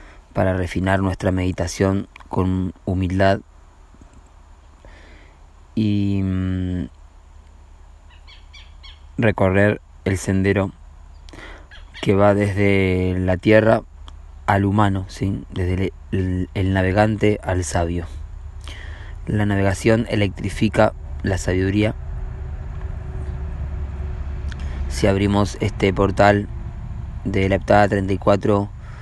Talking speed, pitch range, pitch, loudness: 80 wpm, 75-100 Hz, 90 Hz, -20 LUFS